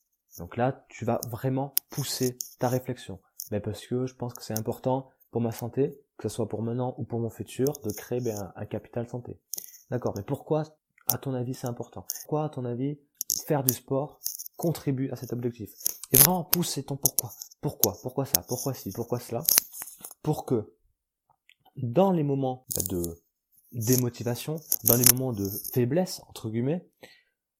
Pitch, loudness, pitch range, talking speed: 125 Hz, -28 LUFS, 115-140 Hz, 170 wpm